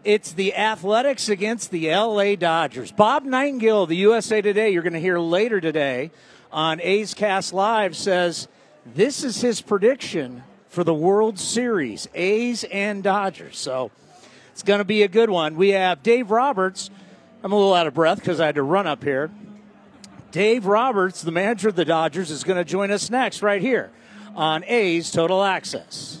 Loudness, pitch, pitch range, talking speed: -21 LUFS, 195 Hz, 170-215 Hz, 180 wpm